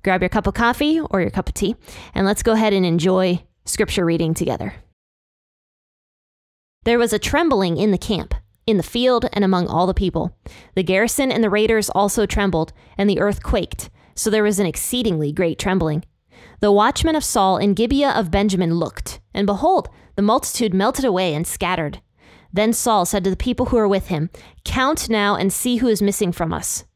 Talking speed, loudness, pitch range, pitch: 195 wpm, -19 LUFS, 180-225 Hz, 200 Hz